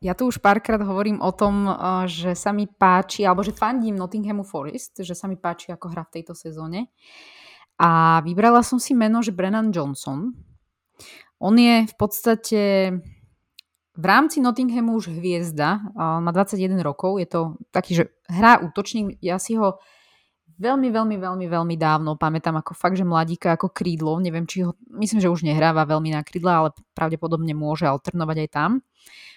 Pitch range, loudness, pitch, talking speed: 165-215 Hz, -21 LUFS, 185 Hz, 170 wpm